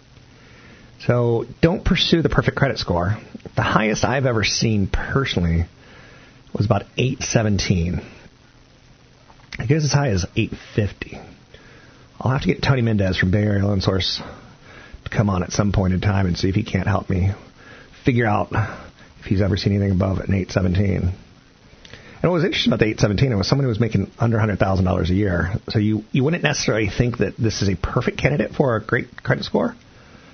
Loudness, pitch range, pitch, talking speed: -20 LUFS, 95-125 Hz, 105 Hz, 195 wpm